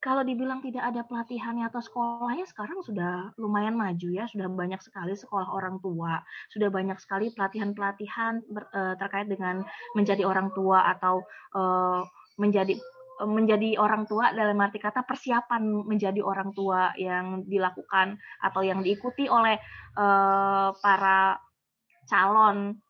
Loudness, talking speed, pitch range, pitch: -27 LUFS, 135 wpm, 190-225 Hz, 200 Hz